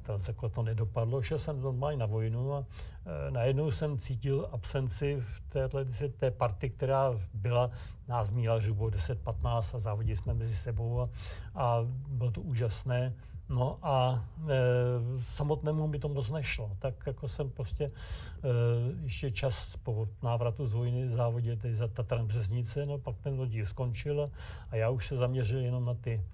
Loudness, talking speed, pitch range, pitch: -33 LUFS, 170 wpm, 110-135 Hz, 120 Hz